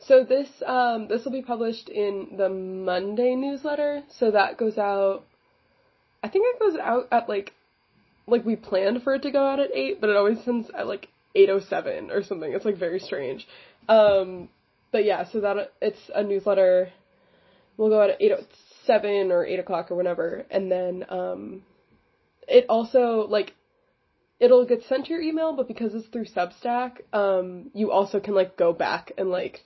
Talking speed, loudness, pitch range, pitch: 190 wpm, -24 LUFS, 195-260 Hz, 215 Hz